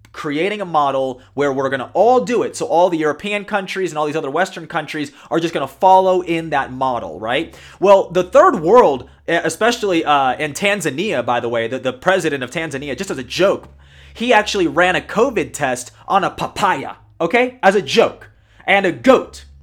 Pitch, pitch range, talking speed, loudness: 165 Hz, 135-190 Hz, 195 wpm, -17 LUFS